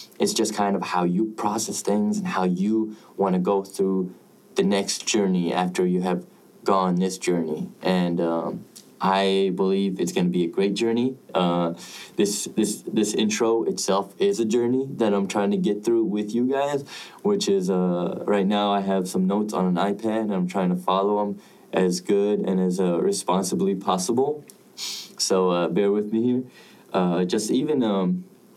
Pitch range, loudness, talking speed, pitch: 90-115 Hz, -24 LUFS, 185 wpm, 100 Hz